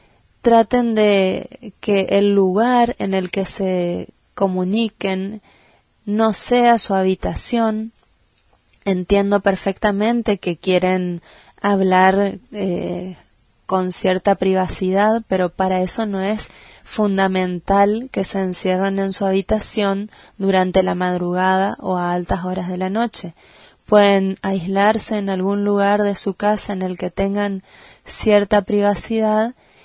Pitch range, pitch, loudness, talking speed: 185-210 Hz, 195 Hz, -17 LUFS, 120 wpm